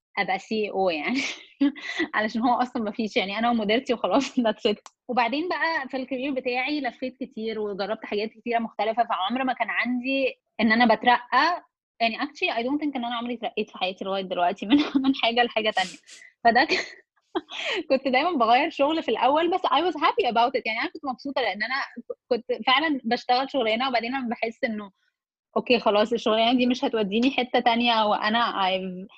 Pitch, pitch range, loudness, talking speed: 245 Hz, 220-275 Hz, -24 LUFS, 180 wpm